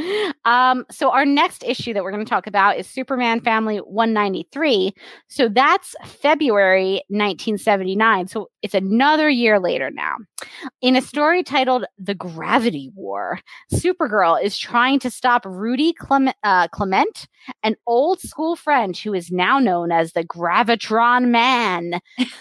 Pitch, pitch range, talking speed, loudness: 235 Hz, 200-270 Hz, 140 wpm, -18 LUFS